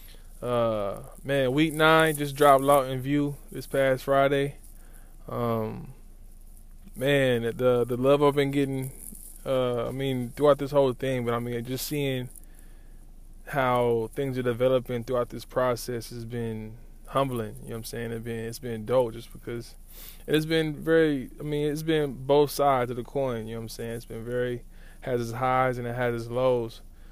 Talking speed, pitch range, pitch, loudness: 185 wpm, 115-140 Hz, 125 Hz, -26 LUFS